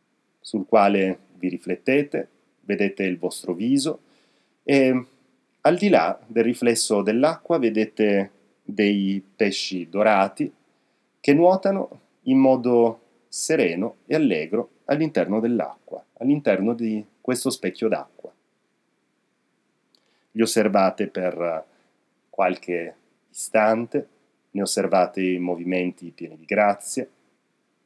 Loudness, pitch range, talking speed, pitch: -22 LUFS, 95-125 Hz, 95 wpm, 110 Hz